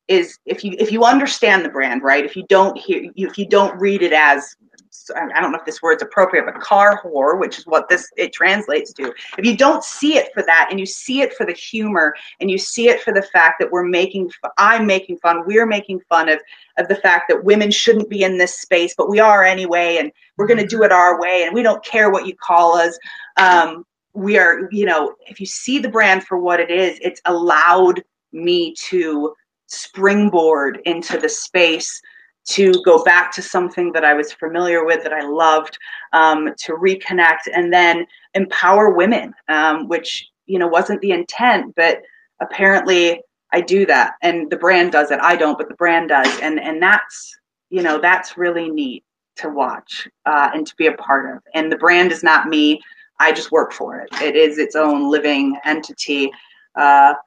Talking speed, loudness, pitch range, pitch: 205 wpm, -15 LUFS, 165-210 Hz, 185 Hz